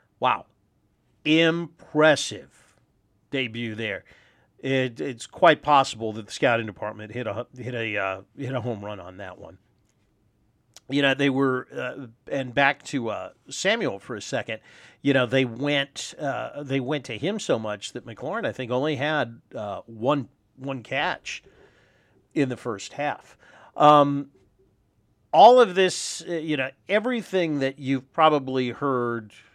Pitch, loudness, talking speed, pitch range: 130 Hz, -24 LUFS, 150 wpm, 110-145 Hz